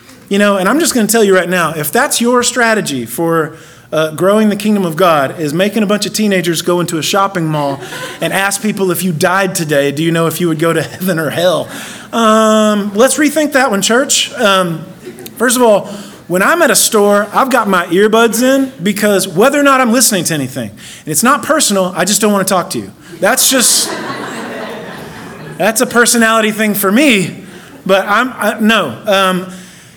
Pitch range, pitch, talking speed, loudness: 175-225 Hz, 195 Hz, 210 wpm, -11 LUFS